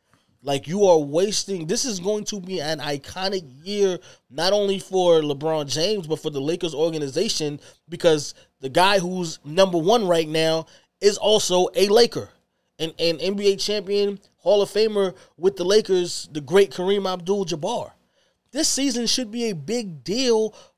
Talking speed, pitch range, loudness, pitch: 160 wpm, 160-205 Hz, -22 LUFS, 185 Hz